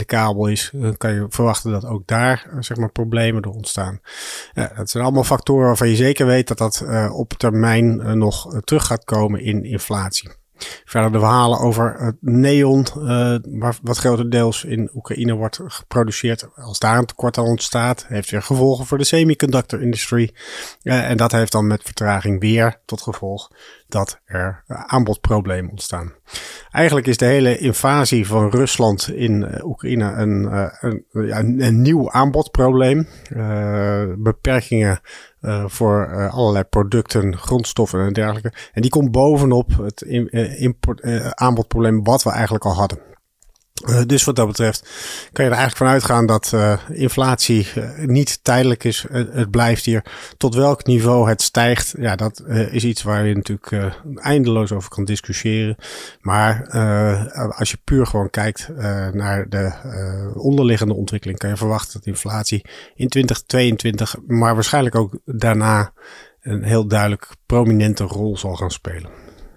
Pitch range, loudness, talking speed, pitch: 105-125 Hz, -18 LUFS, 160 wpm, 115 Hz